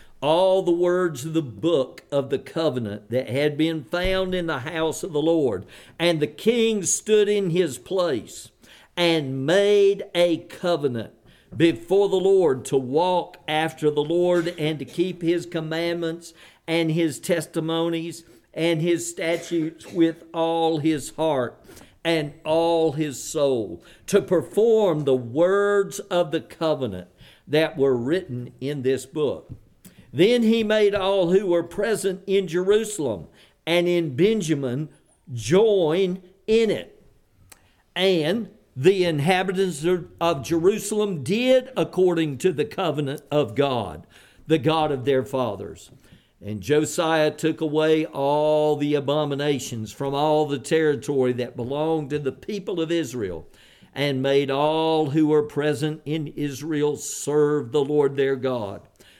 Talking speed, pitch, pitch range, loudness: 135 wpm, 160 Hz, 145-180 Hz, -23 LUFS